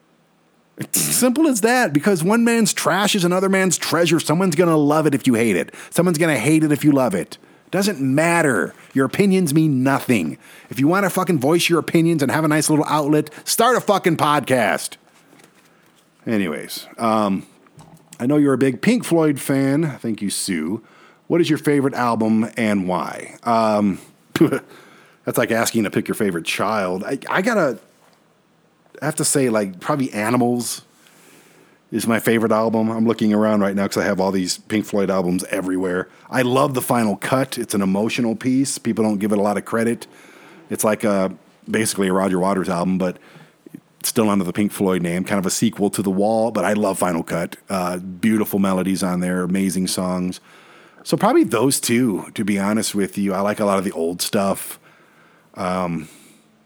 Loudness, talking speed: -19 LUFS, 190 wpm